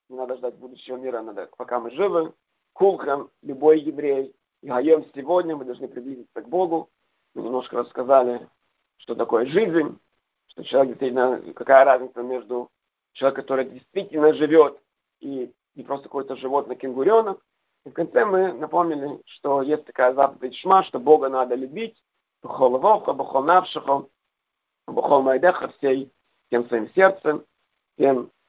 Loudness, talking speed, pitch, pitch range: -22 LUFS, 135 wpm, 135 Hz, 130-160 Hz